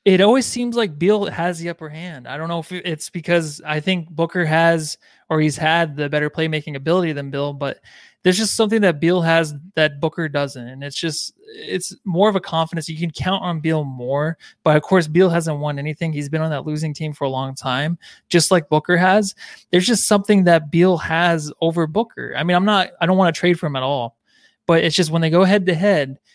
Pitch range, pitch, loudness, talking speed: 155-185 Hz, 165 Hz, -19 LUFS, 235 wpm